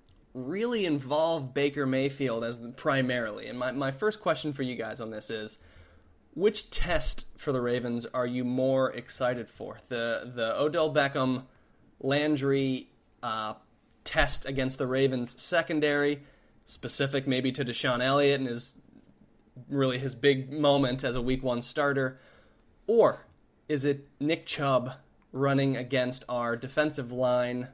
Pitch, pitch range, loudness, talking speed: 130 Hz, 120-140 Hz, -29 LUFS, 140 wpm